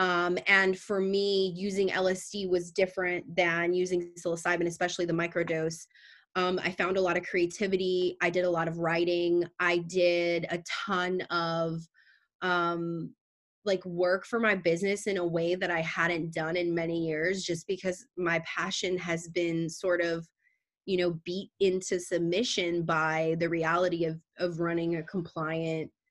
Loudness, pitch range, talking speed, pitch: -29 LUFS, 170-185 Hz, 160 wpm, 175 Hz